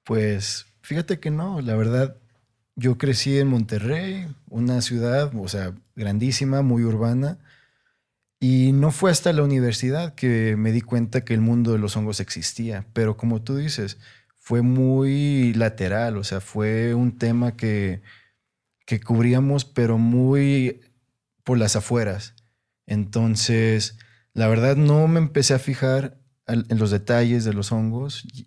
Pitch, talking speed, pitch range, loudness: 120 Hz, 145 wpm, 110-135 Hz, -22 LUFS